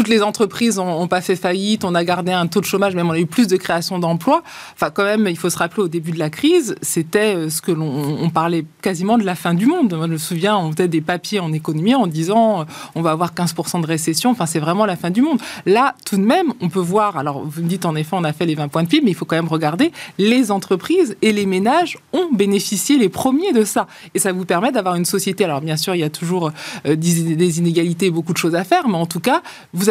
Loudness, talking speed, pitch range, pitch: -18 LUFS, 275 wpm, 170-210 Hz, 180 Hz